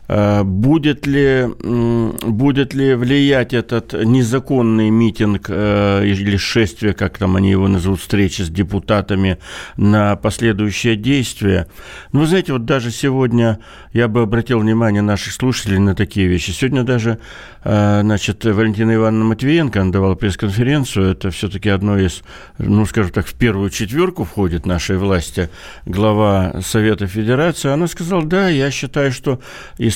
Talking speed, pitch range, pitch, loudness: 140 wpm, 100-125 Hz, 110 Hz, -16 LUFS